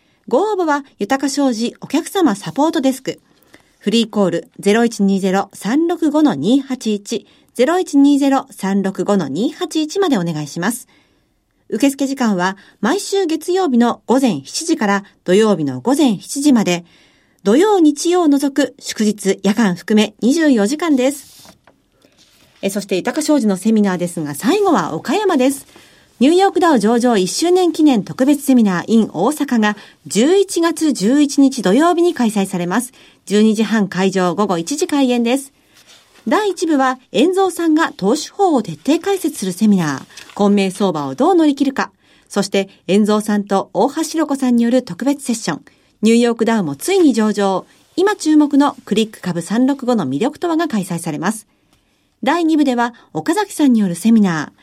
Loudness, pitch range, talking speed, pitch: -16 LUFS, 200-300 Hz, 280 characters per minute, 245 Hz